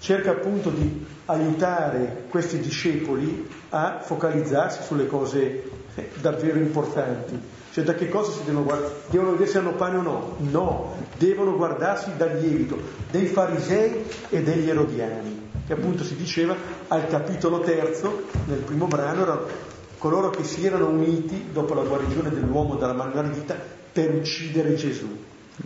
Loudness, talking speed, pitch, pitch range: -25 LUFS, 145 wpm, 160 Hz, 145-180 Hz